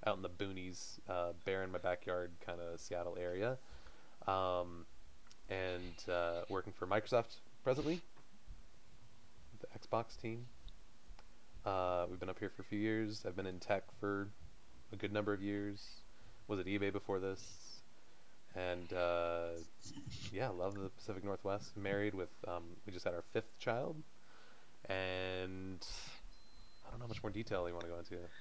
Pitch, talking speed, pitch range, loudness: 95 Hz, 160 wpm, 90-105 Hz, -42 LUFS